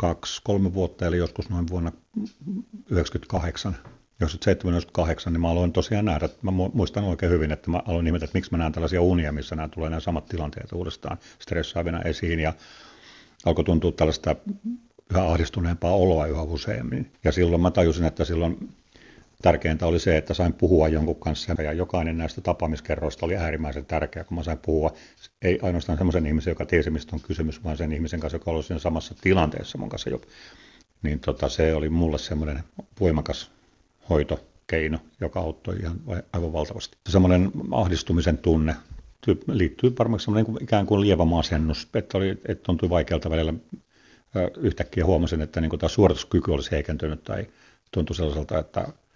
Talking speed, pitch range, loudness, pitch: 160 wpm, 80-90 Hz, -25 LUFS, 85 Hz